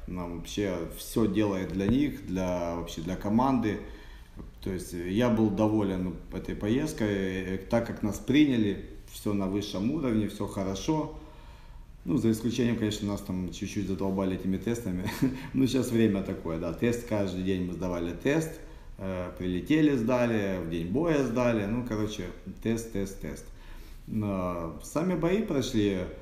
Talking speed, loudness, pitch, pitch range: 150 wpm, -29 LUFS, 100 Hz, 95-115 Hz